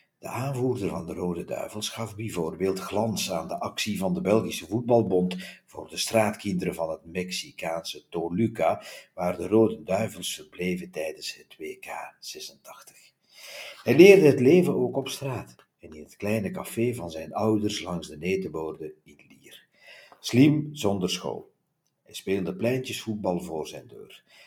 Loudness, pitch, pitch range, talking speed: -26 LUFS, 105 Hz, 90-125 Hz, 150 wpm